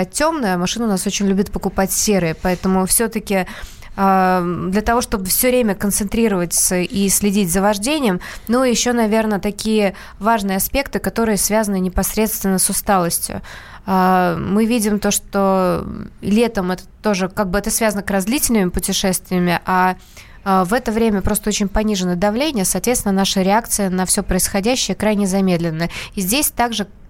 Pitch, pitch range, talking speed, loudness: 200 Hz, 190-220 Hz, 150 wpm, -17 LUFS